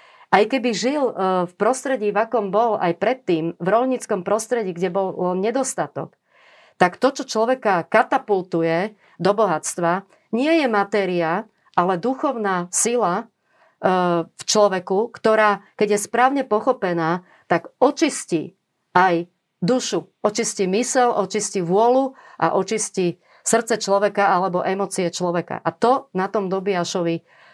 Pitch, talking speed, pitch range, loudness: 205 Hz, 120 wpm, 180-235 Hz, -21 LUFS